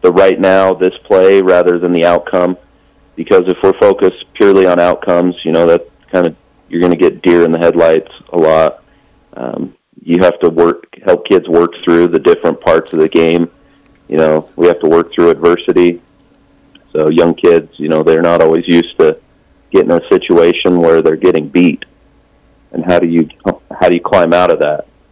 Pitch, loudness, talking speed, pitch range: 85 Hz, -10 LUFS, 200 wpm, 80-90 Hz